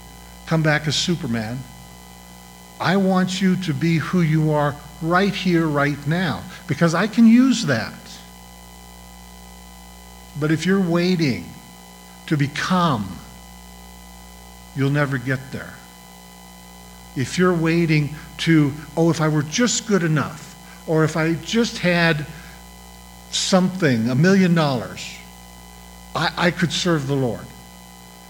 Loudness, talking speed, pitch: -20 LUFS, 120 wpm, 145 Hz